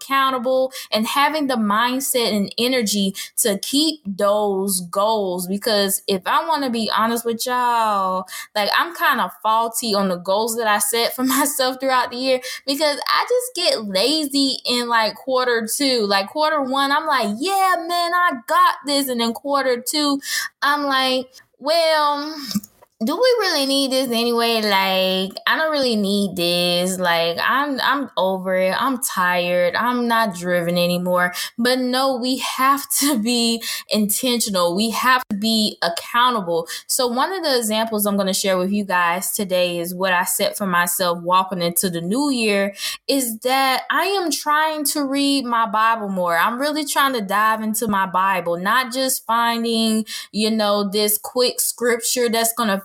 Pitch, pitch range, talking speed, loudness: 235 Hz, 200-275 Hz, 170 wpm, -19 LUFS